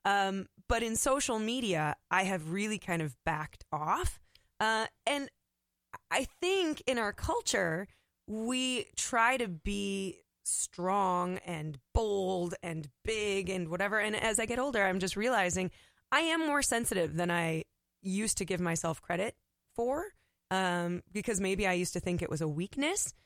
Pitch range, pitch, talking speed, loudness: 180-230 Hz, 195 Hz, 155 wpm, -33 LUFS